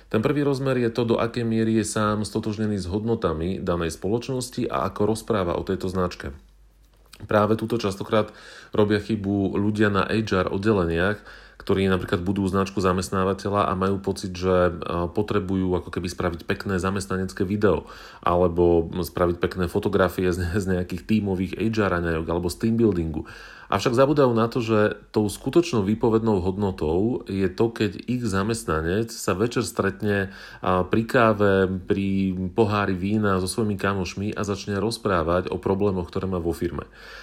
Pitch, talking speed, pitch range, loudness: 100 Hz, 145 wpm, 90-110 Hz, -24 LUFS